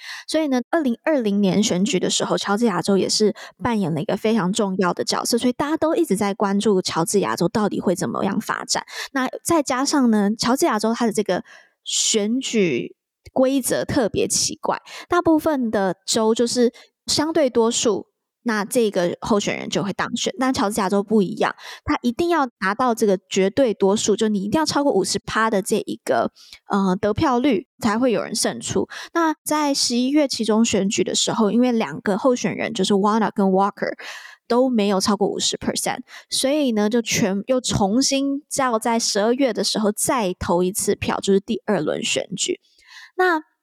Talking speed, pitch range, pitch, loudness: 295 characters per minute, 200-260 Hz, 220 Hz, -20 LUFS